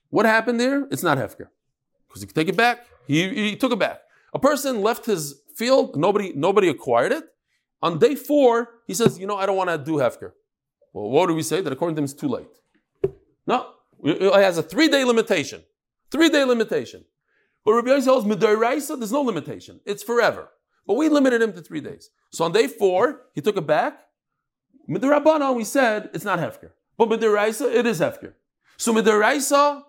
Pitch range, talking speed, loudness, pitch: 200-270 Hz, 195 wpm, -21 LUFS, 230 Hz